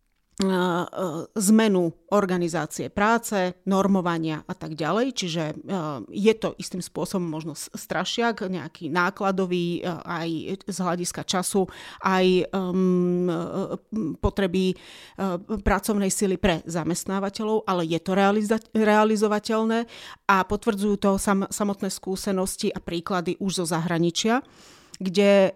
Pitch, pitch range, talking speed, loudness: 190 Hz, 175-205 Hz, 95 wpm, -25 LUFS